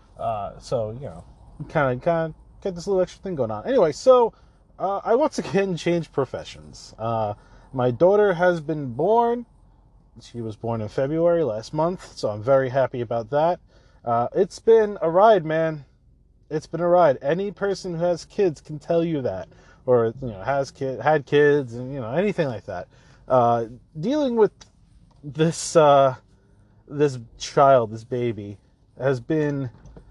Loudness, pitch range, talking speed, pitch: -22 LUFS, 120-170 Hz, 170 wpm, 145 Hz